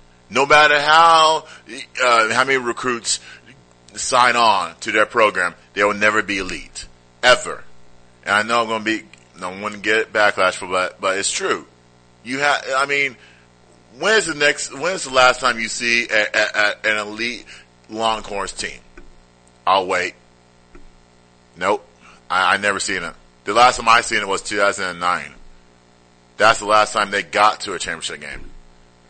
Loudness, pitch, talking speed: -17 LUFS, 95 Hz, 170 wpm